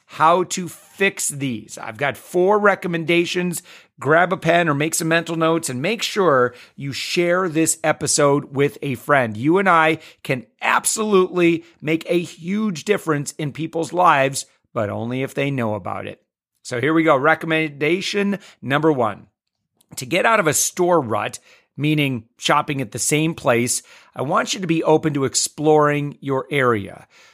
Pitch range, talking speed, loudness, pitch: 135-170 Hz, 165 wpm, -19 LUFS, 155 Hz